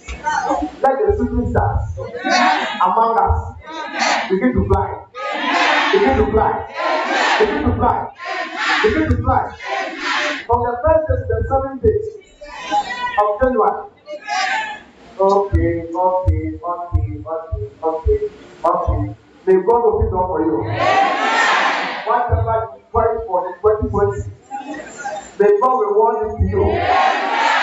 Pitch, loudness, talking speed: 235 Hz, -17 LUFS, 130 wpm